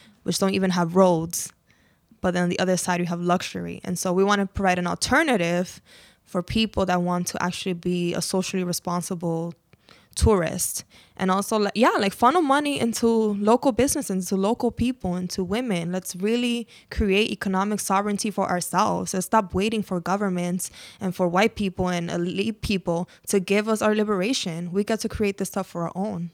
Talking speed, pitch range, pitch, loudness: 185 wpm, 180-215 Hz, 190 Hz, -24 LUFS